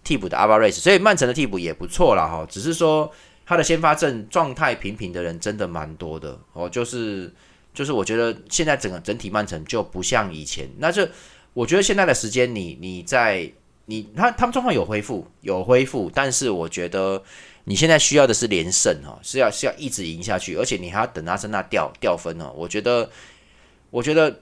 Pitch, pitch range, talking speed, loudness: 110 Hz, 90-150 Hz, 310 characters per minute, -21 LUFS